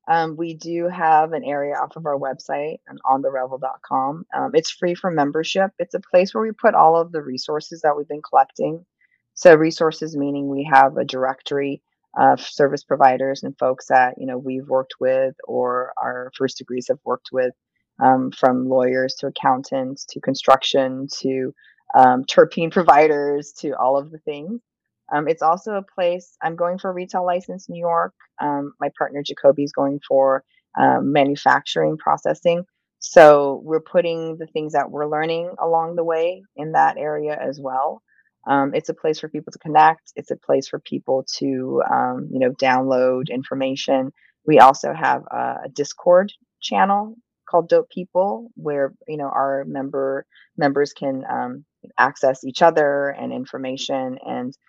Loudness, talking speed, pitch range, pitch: -20 LUFS, 170 wpm, 130-165 Hz, 145 Hz